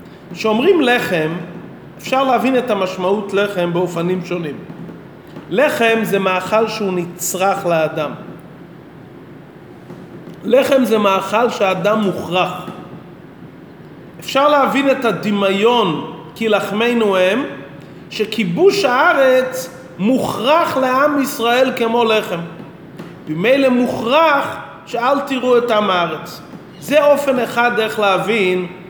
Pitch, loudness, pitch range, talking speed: 210 Hz, -15 LUFS, 180-245 Hz, 95 wpm